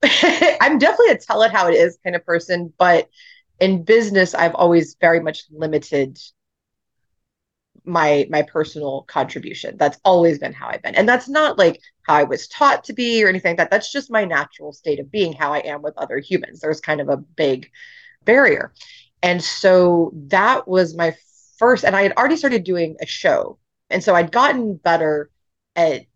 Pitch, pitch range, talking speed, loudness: 175 Hz, 155-225 Hz, 190 wpm, -17 LUFS